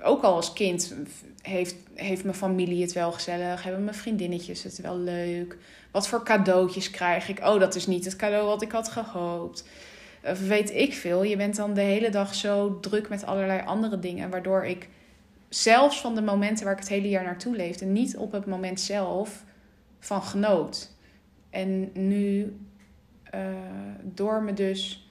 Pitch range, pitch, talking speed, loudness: 180-205 Hz, 195 Hz, 175 wpm, -27 LUFS